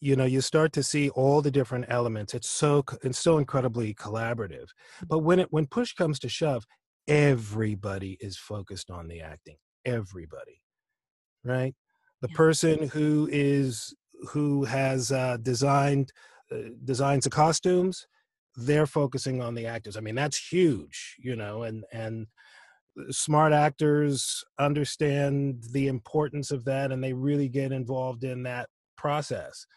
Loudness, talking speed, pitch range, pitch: -27 LUFS, 145 wpm, 120-150 Hz, 135 Hz